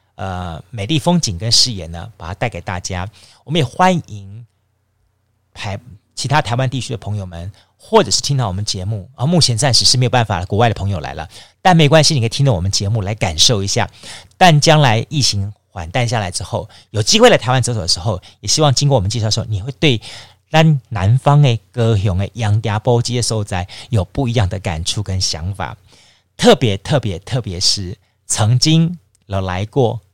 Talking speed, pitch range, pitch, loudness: 300 characters per minute, 100-125 Hz, 110 Hz, -15 LUFS